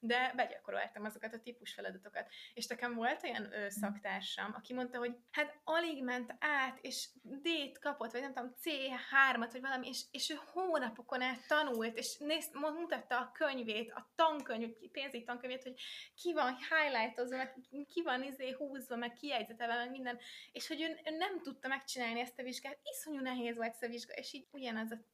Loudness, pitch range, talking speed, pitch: -39 LUFS, 240-290 Hz, 180 wpm, 255 Hz